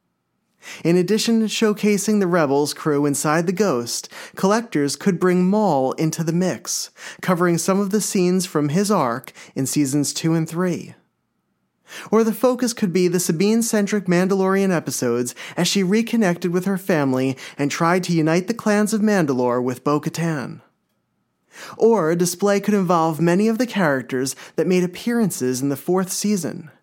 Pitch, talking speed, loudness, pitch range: 180 Hz, 160 wpm, -20 LUFS, 150-205 Hz